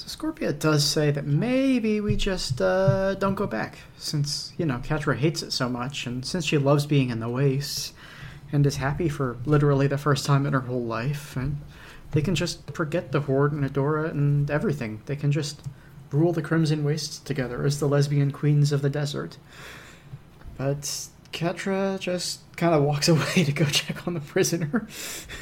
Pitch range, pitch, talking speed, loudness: 140-165 Hz, 145 Hz, 185 wpm, -25 LUFS